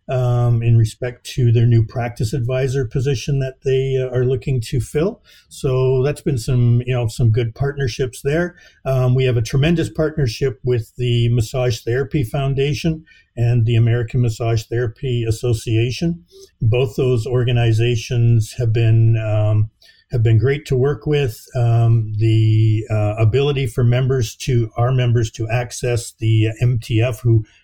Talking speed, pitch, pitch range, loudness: 150 wpm, 125 Hz, 115-135 Hz, -18 LUFS